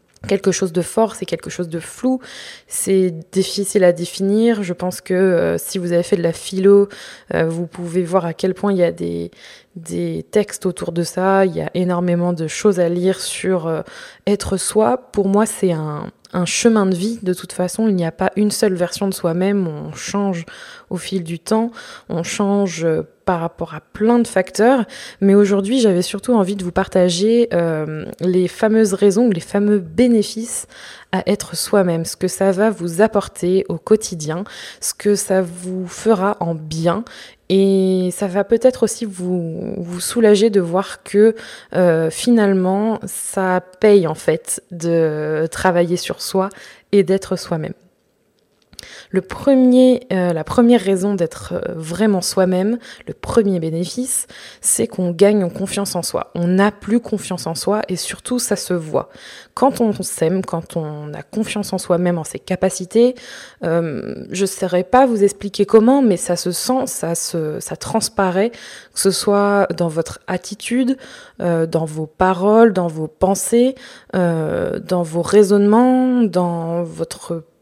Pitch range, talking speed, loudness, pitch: 175-210 Hz, 170 wpm, -18 LUFS, 190 Hz